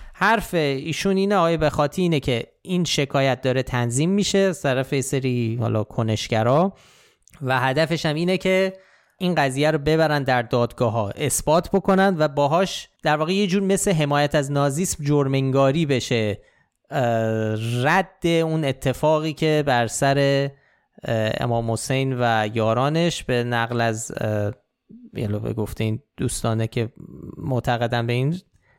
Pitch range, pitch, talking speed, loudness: 120-165 Hz, 140 Hz, 135 wpm, -22 LUFS